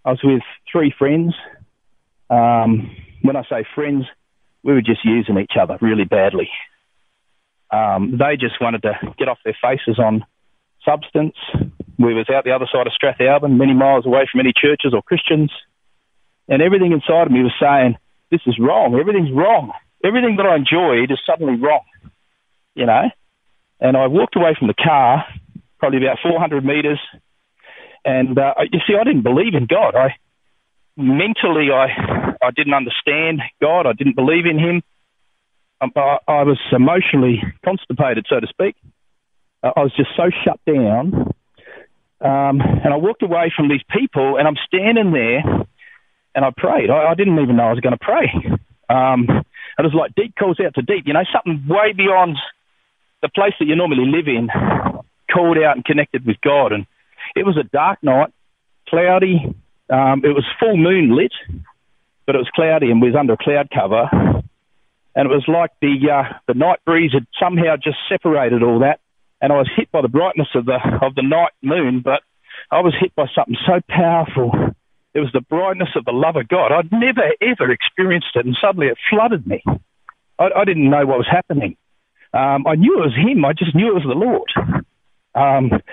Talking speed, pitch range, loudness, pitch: 185 wpm, 125-165 Hz, -16 LUFS, 140 Hz